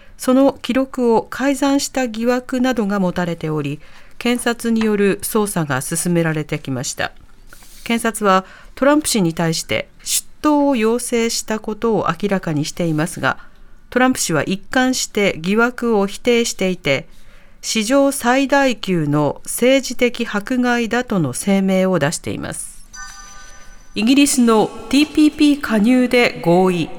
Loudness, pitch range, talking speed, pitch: -17 LUFS, 180-255 Hz, 280 characters per minute, 225 Hz